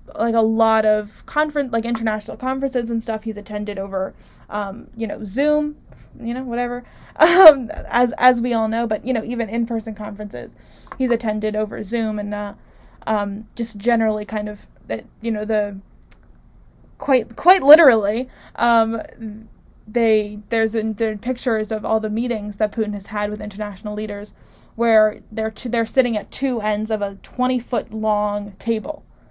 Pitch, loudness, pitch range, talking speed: 220 Hz, -20 LUFS, 210-240 Hz, 160 wpm